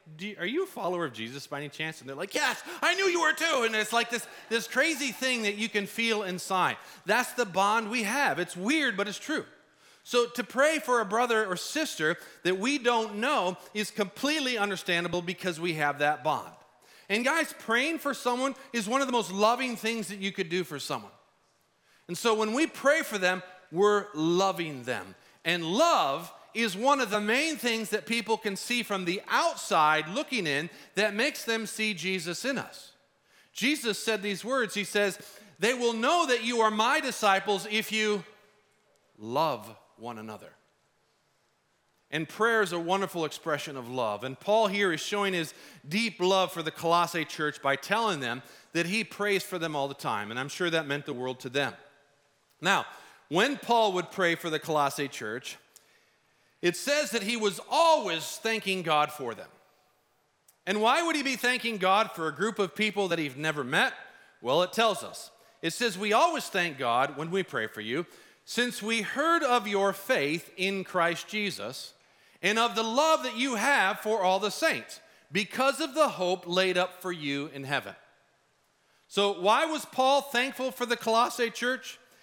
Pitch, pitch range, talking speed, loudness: 205 Hz, 175-240 Hz, 190 wpm, -28 LUFS